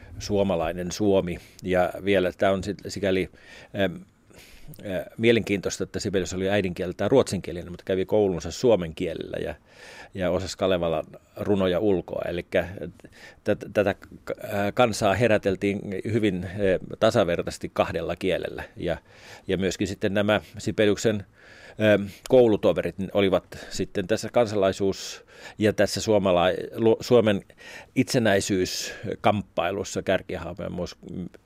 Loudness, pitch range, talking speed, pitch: -25 LUFS, 95-105 Hz, 100 wpm, 100 Hz